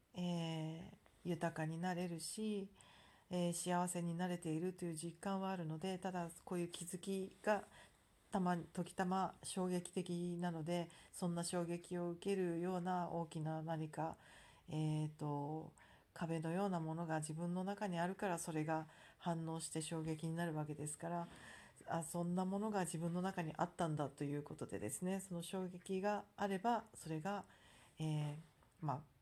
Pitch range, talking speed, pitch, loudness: 160-185 Hz, 300 characters per minute, 175 Hz, -43 LUFS